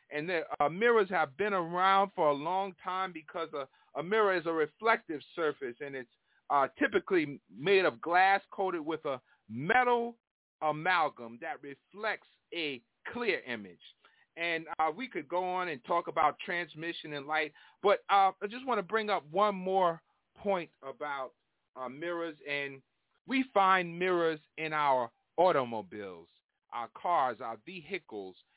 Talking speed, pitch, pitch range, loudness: 155 wpm, 185 Hz, 155-205 Hz, -32 LUFS